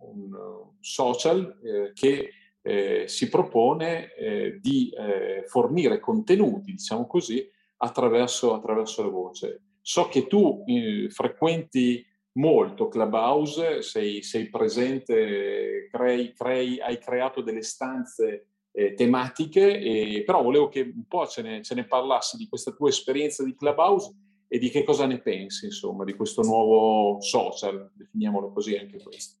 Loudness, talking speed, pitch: -25 LUFS, 140 wpm, 175 Hz